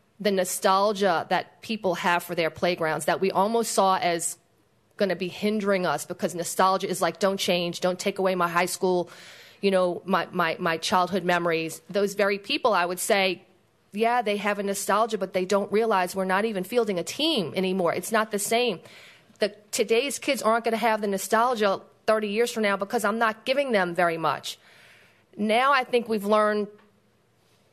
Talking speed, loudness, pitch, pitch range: 190 wpm, -25 LUFS, 195 Hz, 180-215 Hz